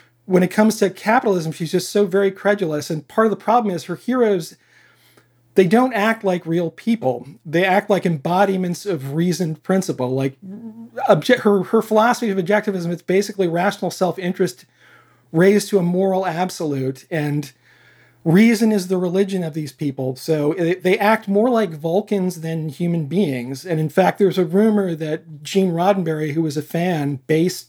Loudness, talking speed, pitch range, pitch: -19 LUFS, 170 wpm, 160-200 Hz, 180 Hz